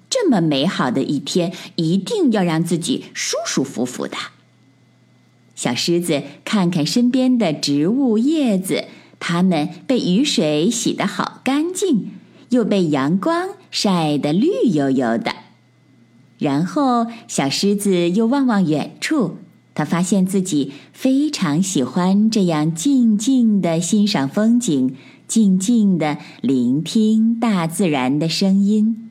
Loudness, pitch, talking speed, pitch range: -18 LUFS, 195 Hz, 185 characters per minute, 155-230 Hz